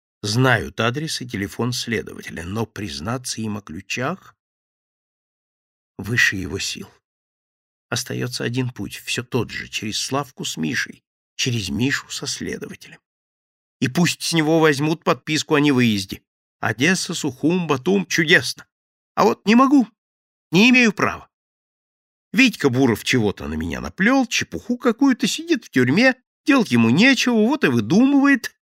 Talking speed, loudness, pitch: 130 wpm, -19 LUFS, 150 Hz